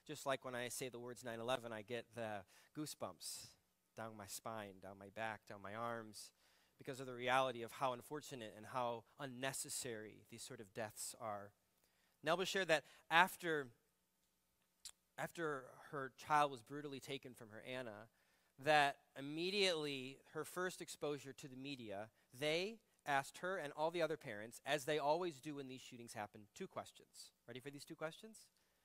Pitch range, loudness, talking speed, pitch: 115-150 Hz, -44 LUFS, 170 wpm, 130 Hz